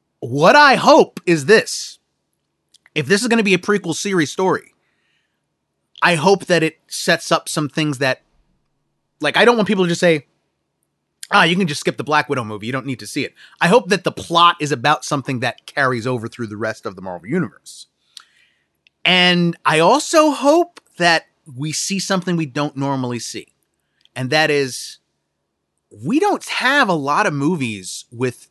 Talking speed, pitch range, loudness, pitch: 185 wpm, 140-185 Hz, -16 LUFS, 160 Hz